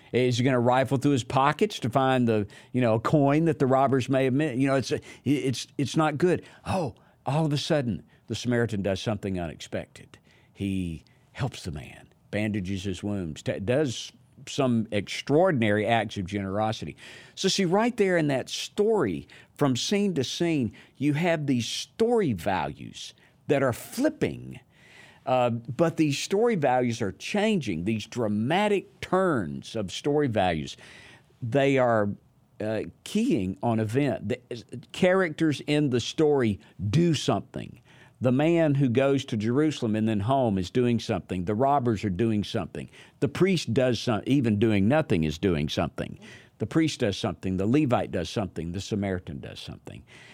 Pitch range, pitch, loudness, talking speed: 105-145 Hz, 125 Hz, -26 LUFS, 160 wpm